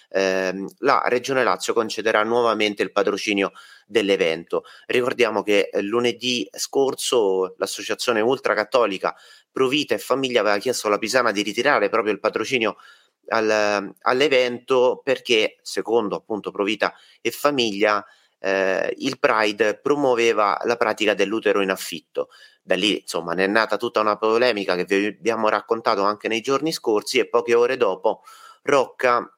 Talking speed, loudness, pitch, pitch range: 140 wpm, -21 LUFS, 115 Hz, 105-140 Hz